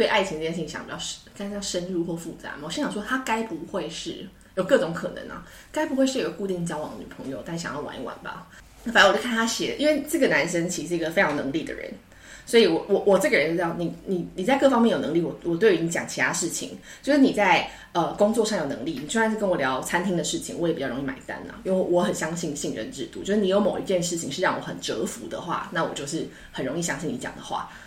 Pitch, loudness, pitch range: 195 Hz, -25 LUFS, 170-230 Hz